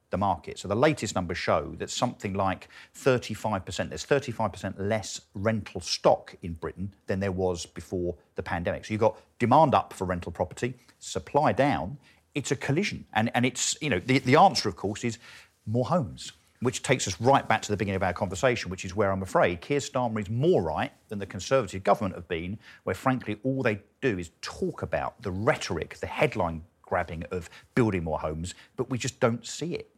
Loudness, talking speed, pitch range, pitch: -28 LUFS, 200 wpm, 95-125 Hz, 105 Hz